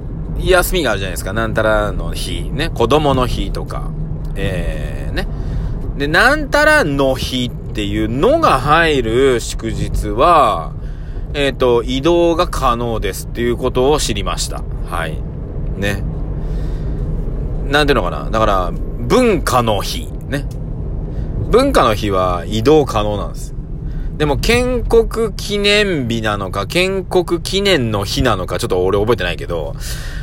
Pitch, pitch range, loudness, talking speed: 130 Hz, 110-170 Hz, -16 LUFS, 260 characters per minute